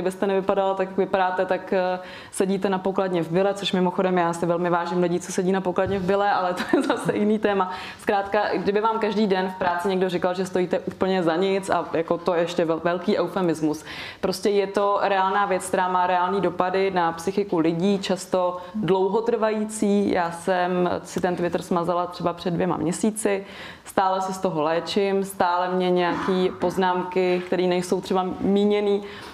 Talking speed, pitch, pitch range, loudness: 180 wpm, 185 Hz, 180-200 Hz, -23 LUFS